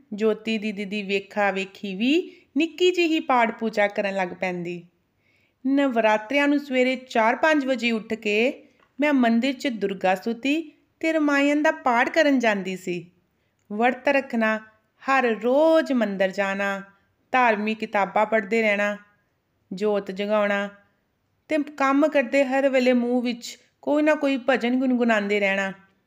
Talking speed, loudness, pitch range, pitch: 130 wpm, -23 LUFS, 205-275 Hz, 230 Hz